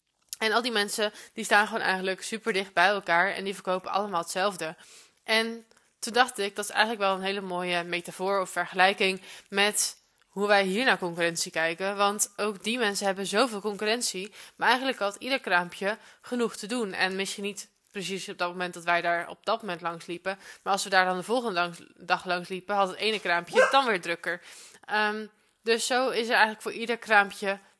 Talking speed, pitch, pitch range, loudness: 200 wpm, 200 Hz, 180-215 Hz, -27 LUFS